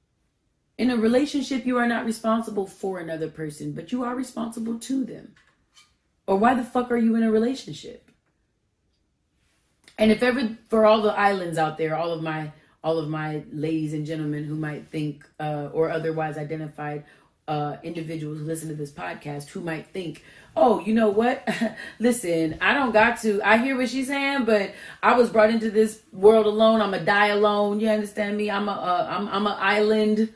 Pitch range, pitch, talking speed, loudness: 160-225 Hz, 205 Hz, 190 wpm, -23 LUFS